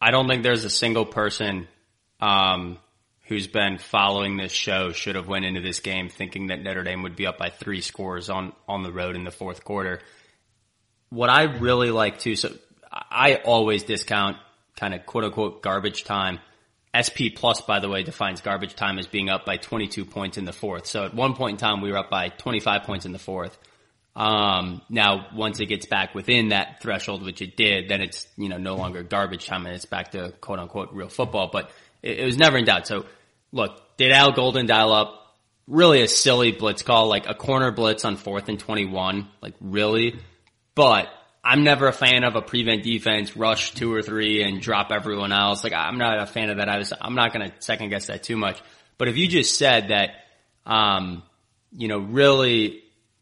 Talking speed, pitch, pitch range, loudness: 210 wpm, 105 Hz, 95-115 Hz, -22 LUFS